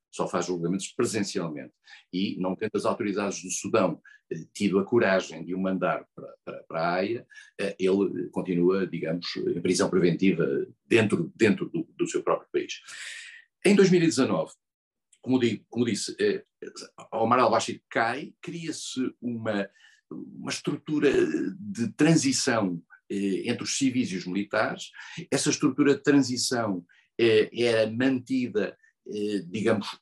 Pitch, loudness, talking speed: 120 Hz, -26 LUFS, 140 wpm